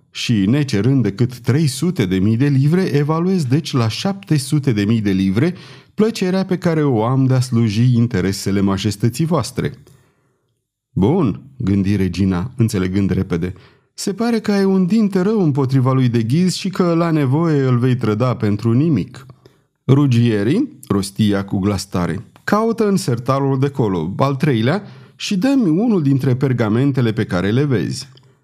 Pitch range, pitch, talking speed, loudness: 110-160 Hz, 130 Hz, 150 wpm, -17 LUFS